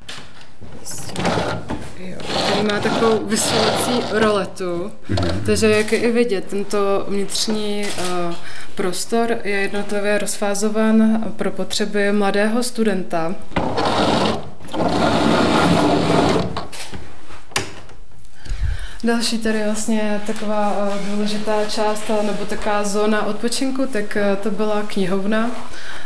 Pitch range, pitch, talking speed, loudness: 200-220 Hz, 210 Hz, 80 wpm, -20 LUFS